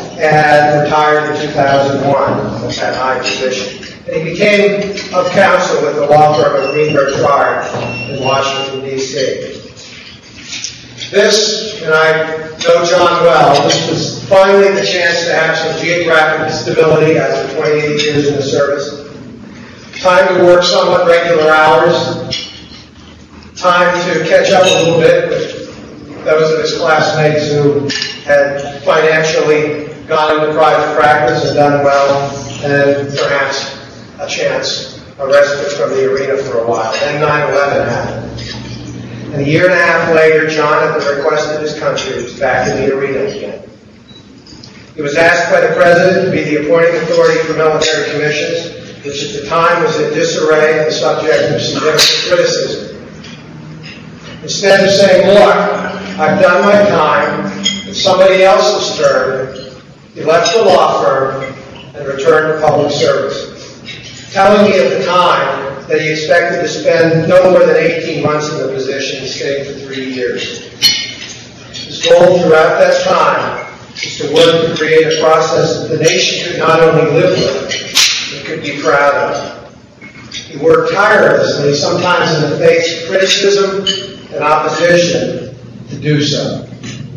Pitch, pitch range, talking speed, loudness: 155 Hz, 145-180 Hz, 150 wpm, -11 LUFS